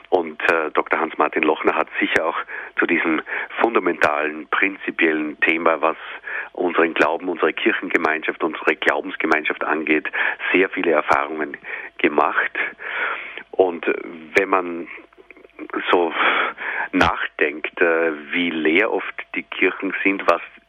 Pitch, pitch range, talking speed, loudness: 80 Hz, 75-85 Hz, 110 wpm, -20 LUFS